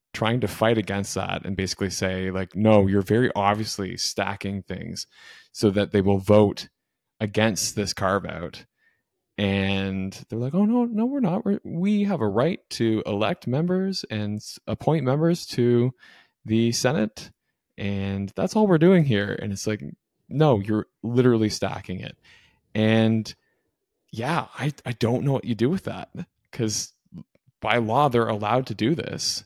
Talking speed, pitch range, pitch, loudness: 160 wpm, 100-130 Hz, 110 Hz, -24 LUFS